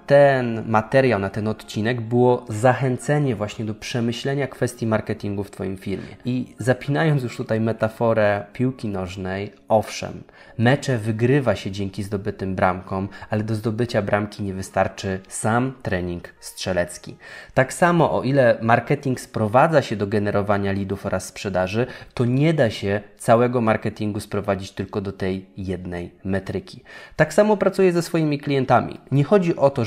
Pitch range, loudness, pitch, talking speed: 100-130 Hz, -22 LUFS, 110 Hz, 145 wpm